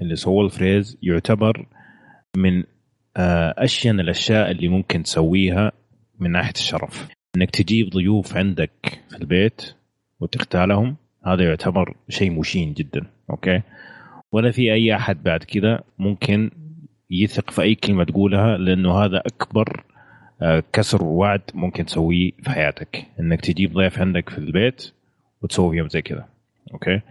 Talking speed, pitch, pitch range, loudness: 125 wpm, 95 Hz, 90-105 Hz, -20 LUFS